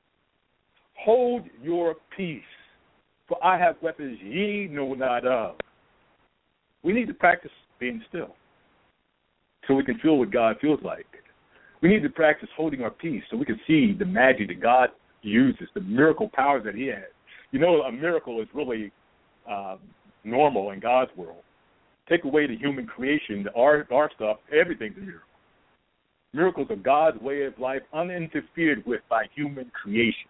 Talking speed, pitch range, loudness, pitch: 160 wpm, 120-170 Hz, -25 LUFS, 145 Hz